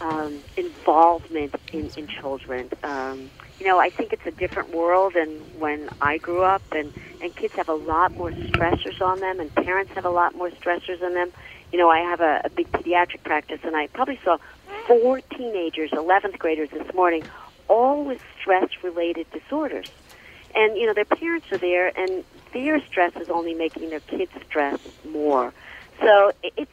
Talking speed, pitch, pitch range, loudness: 180 wpm, 180 Hz, 160-210 Hz, -23 LUFS